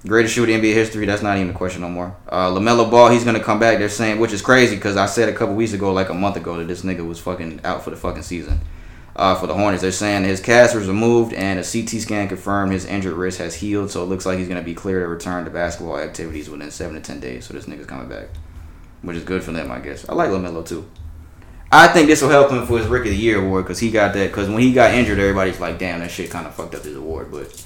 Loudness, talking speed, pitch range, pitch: -17 LUFS, 295 wpm, 85-110 Hz, 95 Hz